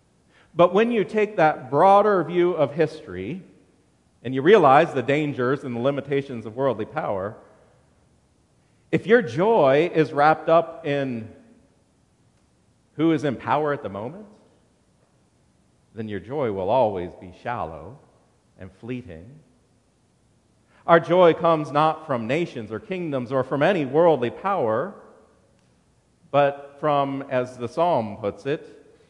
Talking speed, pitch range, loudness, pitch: 130 wpm, 125-165 Hz, -22 LUFS, 145 Hz